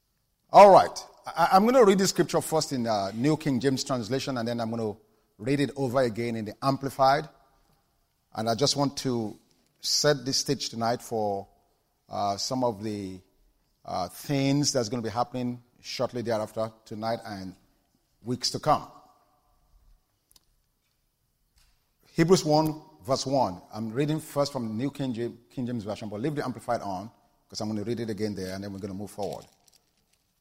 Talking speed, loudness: 175 wpm, -26 LUFS